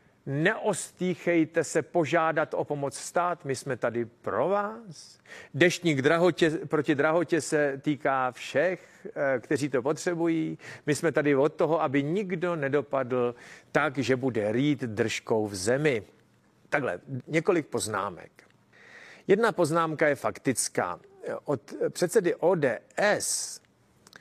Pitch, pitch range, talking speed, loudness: 155 Hz, 135-175 Hz, 115 wpm, -27 LUFS